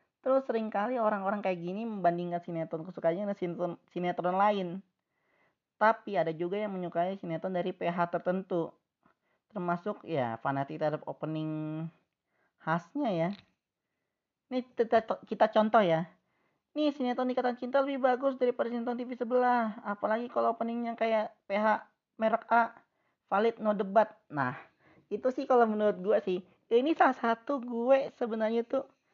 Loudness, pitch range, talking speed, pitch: -31 LUFS, 175-240 Hz, 135 wpm, 215 Hz